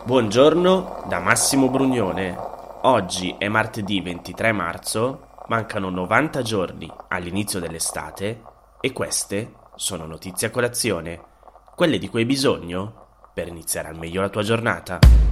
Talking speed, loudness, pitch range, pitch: 125 wpm, -22 LUFS, 90-115 Hz, 100 Hz